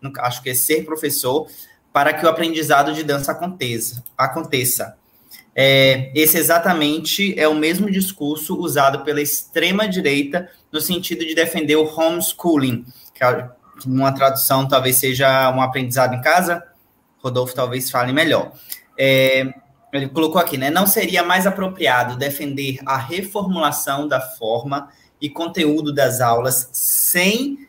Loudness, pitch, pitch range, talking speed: -17 LUFS, 145 Hz, 130-165 Hz, 130 wpm